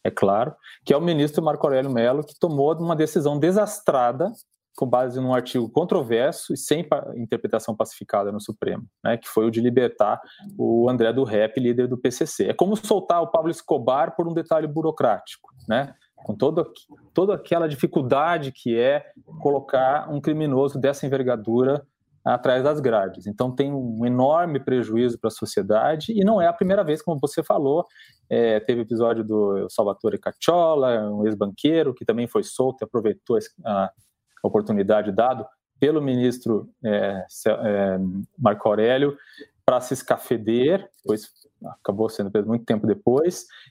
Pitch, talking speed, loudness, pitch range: 130 Hz, 155 wpm, -22 LUFS, 115-160 Hz